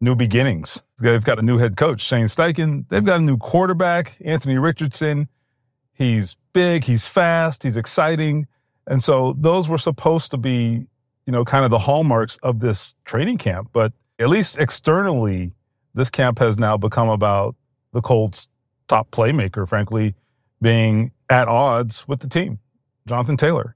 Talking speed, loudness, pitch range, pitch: 160 wpm, -19 LUFS, 115-150 Hz, 125 Hz